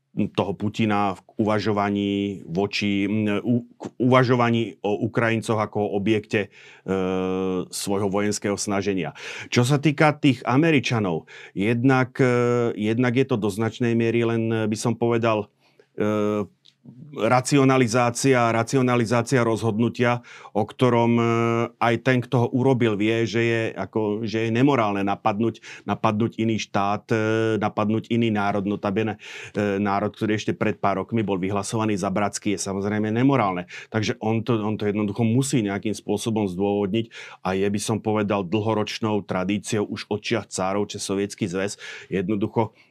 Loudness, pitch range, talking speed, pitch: -23 LUFS, 100-115 Hz, 135 wpm, 110 Hz